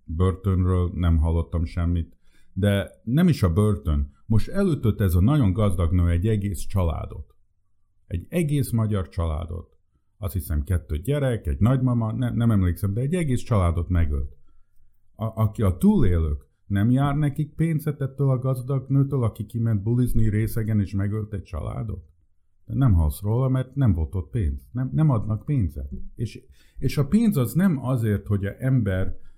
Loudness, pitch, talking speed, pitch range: -24 LUFS, 100 Hz, 165 wpm, 90-125 Hz